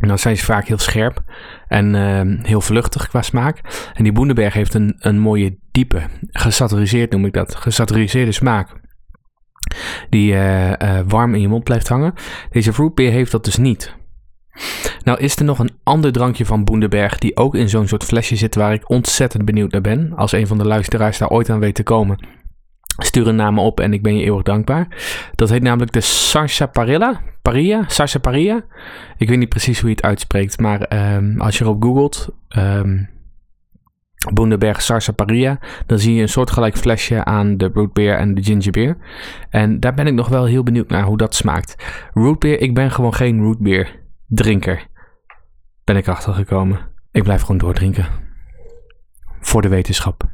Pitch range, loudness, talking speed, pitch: 100-120 Hz, -16 LUFS, 185 wpm, 110 Hz